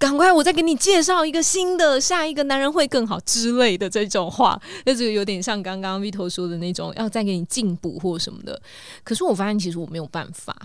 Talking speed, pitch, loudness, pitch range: 345 characters per minute, 220 Hz, -20 LUFS, 185-290 Hz